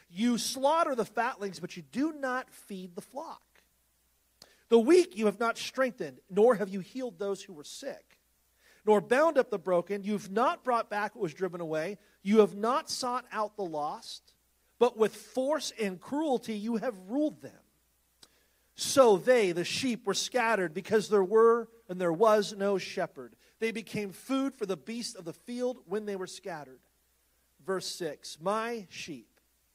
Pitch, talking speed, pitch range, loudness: 210 Hz, 175 wpm, 185-240 Hz, -30 LUFS